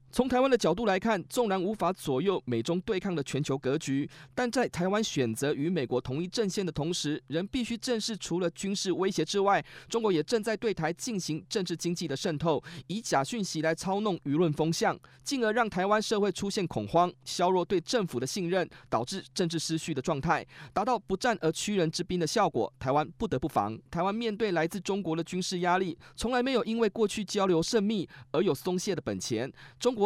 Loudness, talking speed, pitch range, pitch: -30 LUFS, 315 characters per minute, 160-215 Hz, 185 Hz